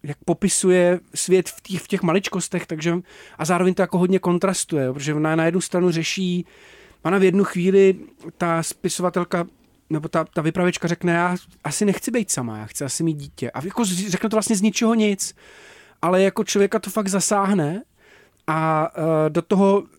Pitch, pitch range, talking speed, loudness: 180 Hz, 165-195 Hz, 180 wpm, -21 LUFS